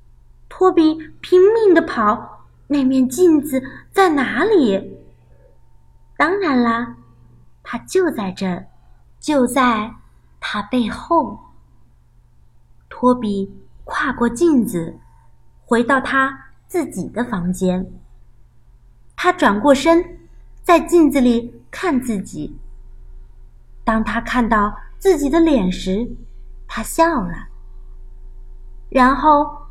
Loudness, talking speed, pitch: -17 LUFS, 130 characters per minute, 240 Hz